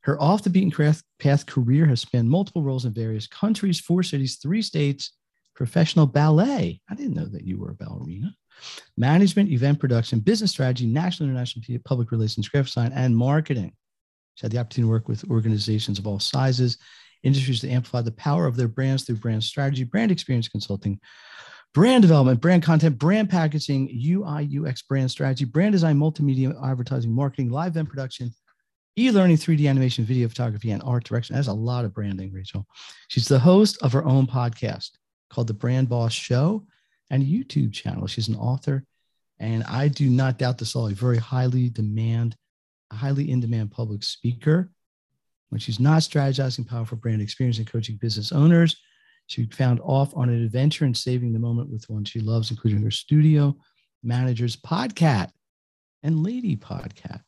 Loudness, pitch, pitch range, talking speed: -23 LUFS, 130 Hz, 115-150 Hz, 170 wpm